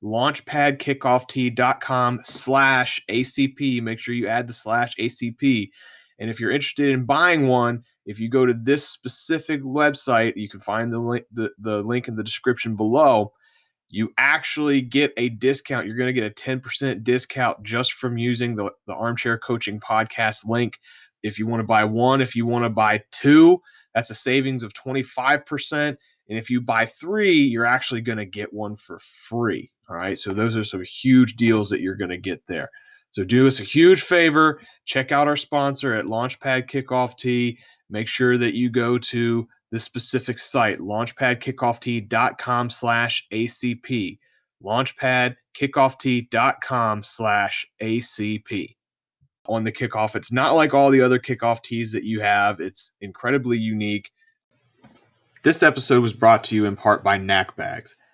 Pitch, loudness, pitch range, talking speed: 120 Hz, -21 LUFS, 115-135 Hz, 165 wpm